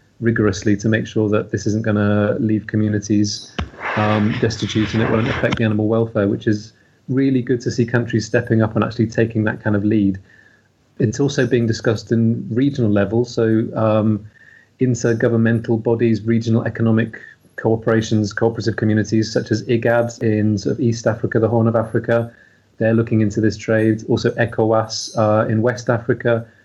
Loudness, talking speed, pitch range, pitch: -18 LUFS, 170 wpm, 110-115 Hz, 115 Hz